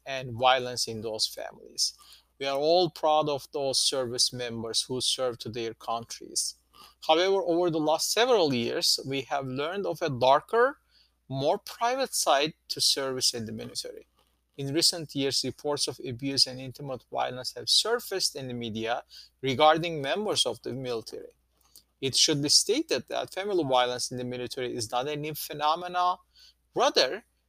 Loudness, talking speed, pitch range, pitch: -27 LUFS, 160 wpm, 125-165 Hz, 140 Hz